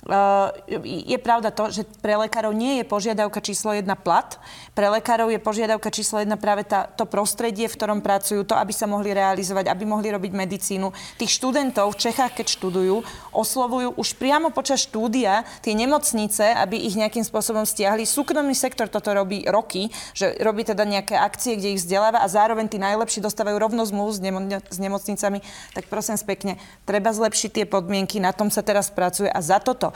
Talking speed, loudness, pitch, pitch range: 180 wpm, -22 LUFS, 215 Hz, 200-225 Hz